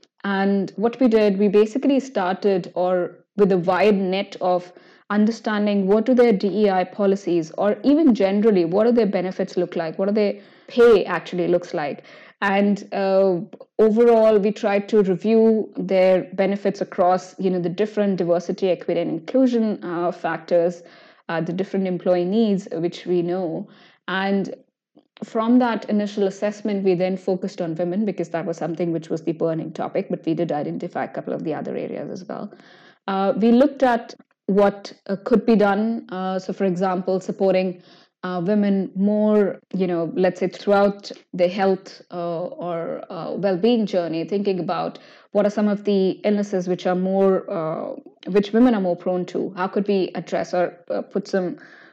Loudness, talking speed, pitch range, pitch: -21 LUFS, 170 wpm, 180-210 Hz, 195 Hz